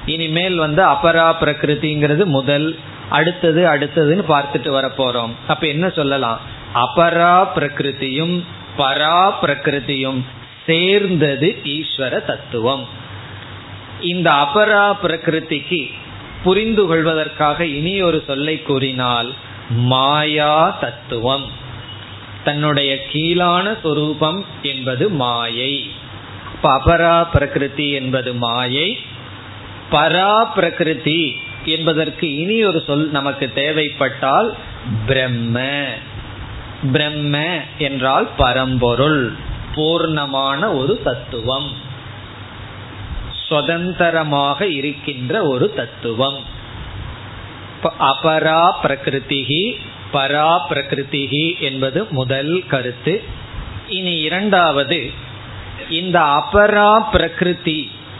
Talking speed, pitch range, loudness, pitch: 70 wpm, 125-160 Hz, -16 LUFS, 145 Hz